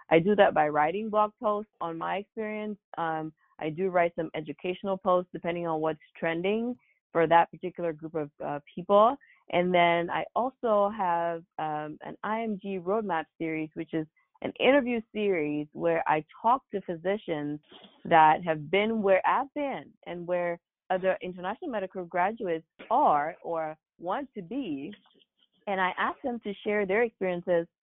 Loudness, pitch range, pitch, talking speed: -29 LUFS, 165-210 Hz, 180 Hz, 155 wpm